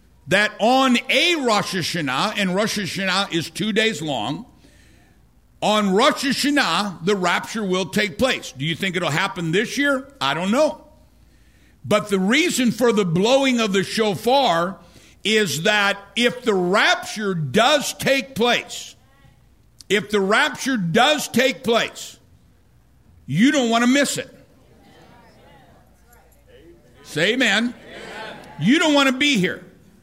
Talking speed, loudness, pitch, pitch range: 135 wpm, -19 LUFS, 215 Hz, 190-255 Hz